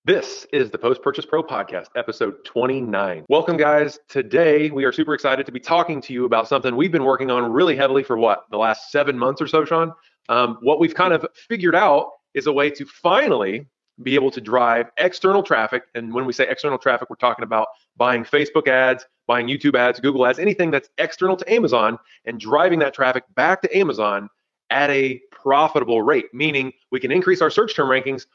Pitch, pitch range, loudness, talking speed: 140 Hz, 125-160 Hz, -19 LUFS, 205 wpm